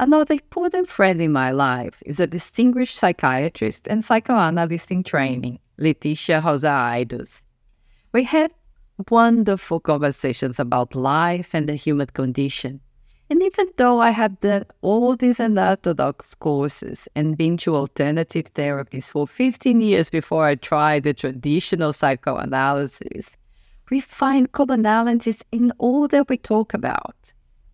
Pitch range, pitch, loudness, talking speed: 140-230 Hz, 165 Hz, -20 LUFS, 130 wpm